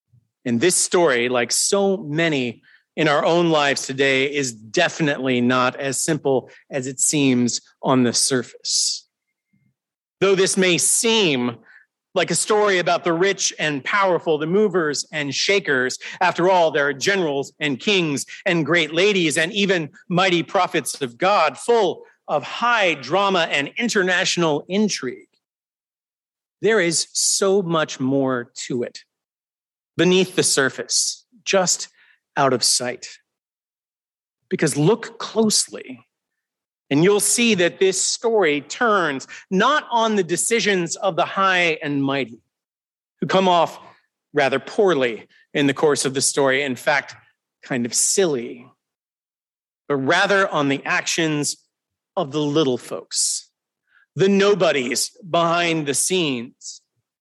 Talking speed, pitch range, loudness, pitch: 130 wpm, 140-195 Hz, -19 LUFS, 165 Hz